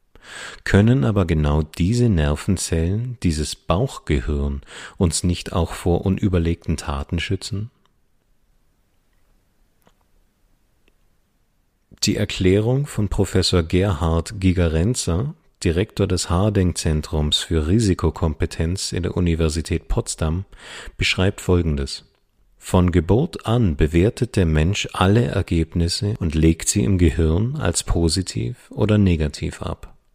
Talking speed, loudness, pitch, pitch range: 100 wpm, -20 LUFS, 90 Hz, 80-100 Hz